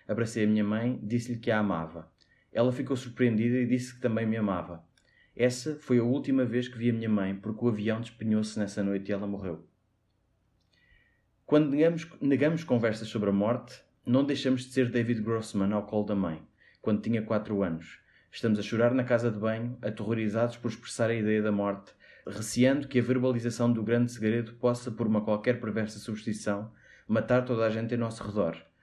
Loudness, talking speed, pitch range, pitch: -29 LUFS, 190 wpm, 105-120 Hz, 110 Hz